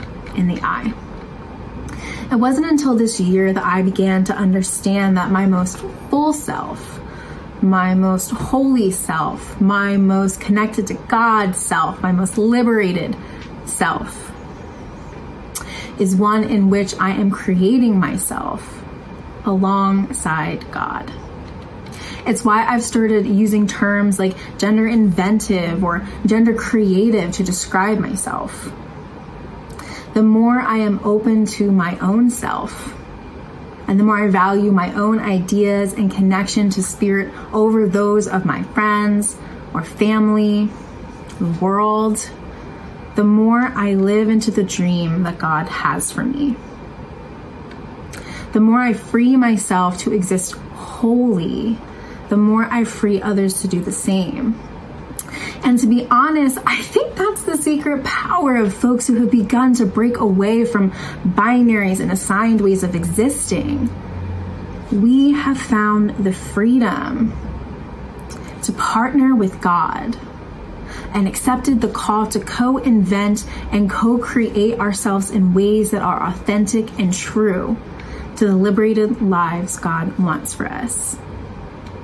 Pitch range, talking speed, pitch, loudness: 190-230 Hz, 130 wpm, 210 Hz, -17 LUFS